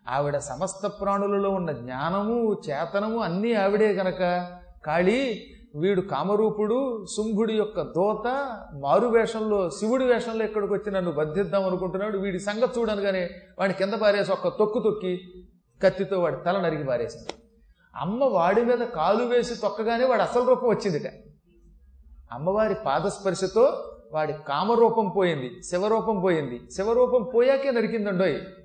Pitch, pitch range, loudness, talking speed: 200 Hz, 180-225 Hz, -25 LUFS, 125 wpm